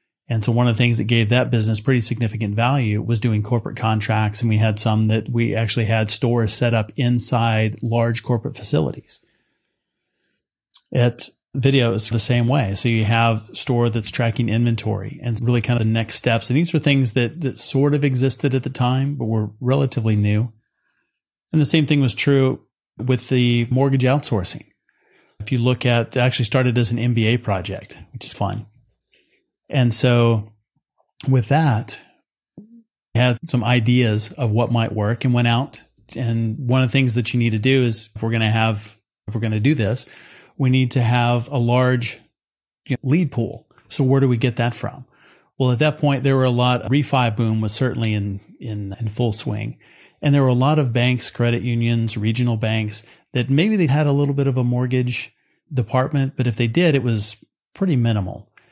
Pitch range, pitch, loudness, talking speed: 115-130 Hz, 120 Hz, -19 LUFS, 195 wpm